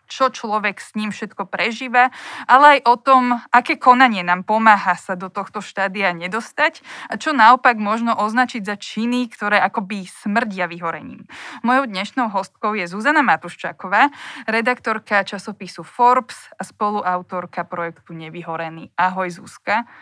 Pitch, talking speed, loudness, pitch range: 215 Hz, 135 wpm, -18 LUFS, 190-245 Hz